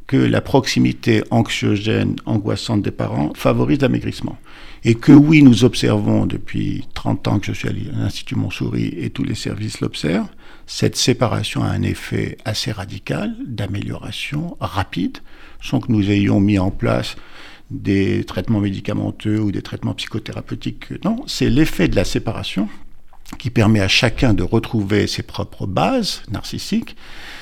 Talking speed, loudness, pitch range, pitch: 145 wpm, -18 LUFS, 100-125 Hz, 110 Hz